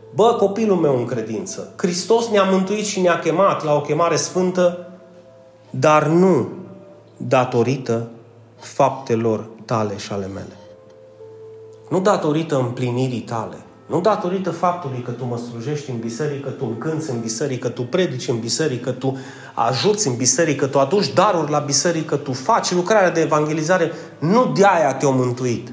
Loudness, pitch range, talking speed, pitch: -19 LUFS, 120-175 Hz, 160 wpm, 145 Hz